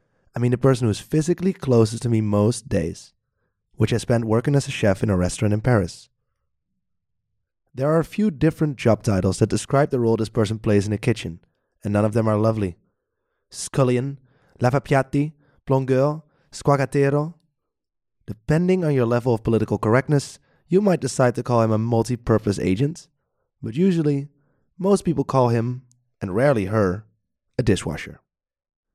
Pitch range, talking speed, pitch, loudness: 110-145 Hz, 160 wpm, 125 Hz, -21 LUFS